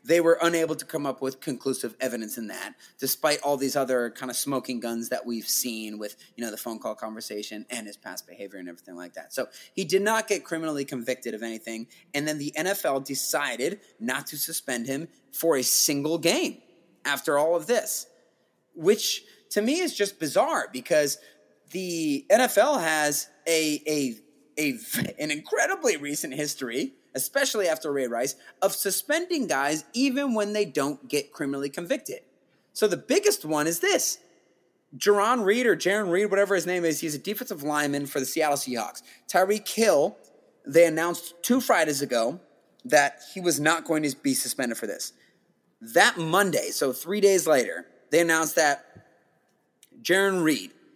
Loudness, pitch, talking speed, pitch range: -26 LUFS, 155 Hz, 170 wpm, 135-195 Hz